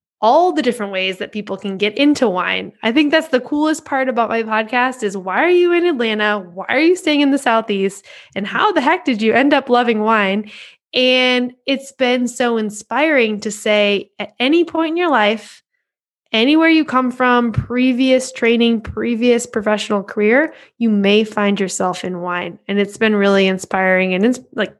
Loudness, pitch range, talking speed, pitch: -16 LUFS, 205-265 Hz, 190 wpm, 230 Hz